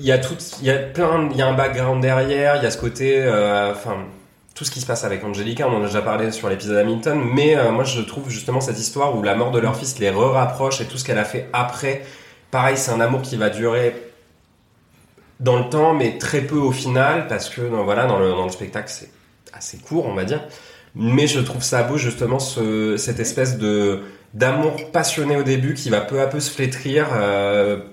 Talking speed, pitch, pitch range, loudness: 240 wpm, 125 Hz, 110-135 Hz, -20 LUFS